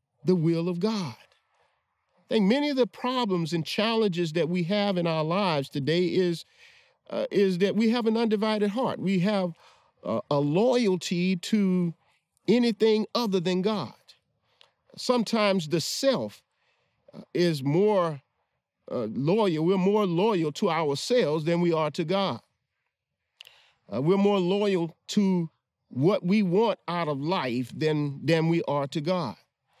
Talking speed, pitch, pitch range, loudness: 145 wpm, 185 Hz, 165-210 Hz, -26 LUFS